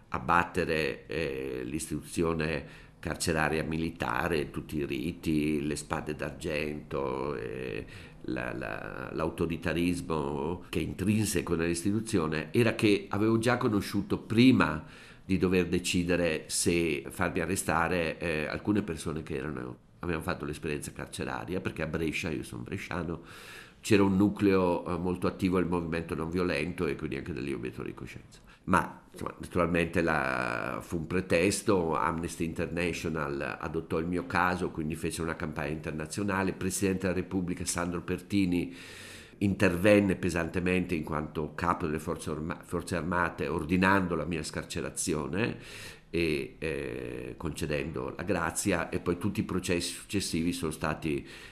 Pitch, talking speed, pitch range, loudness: 85 Hz, 130 wpm, 80-95 Hz, -31 LUFS